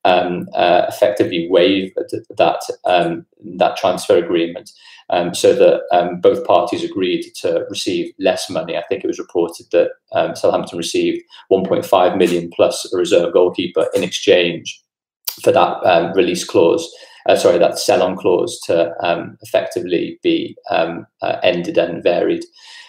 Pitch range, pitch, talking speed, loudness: 335-485 Hz, 370 Hz, 145 wpm, -16 LUFS